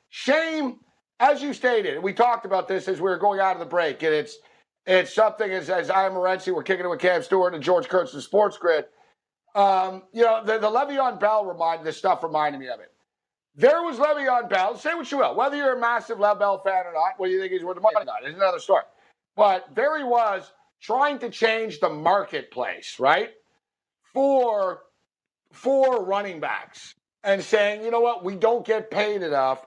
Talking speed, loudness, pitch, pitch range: 210 wpm, -23 LUFS, 210 Hz, 185-250 Hz